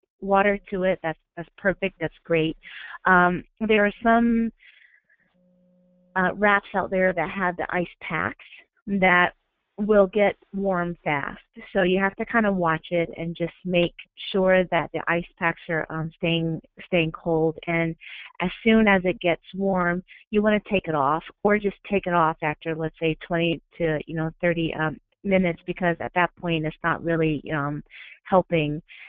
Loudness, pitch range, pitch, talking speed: -24 LUFS, 165-195 Hz, 175 Hz, 175 wpm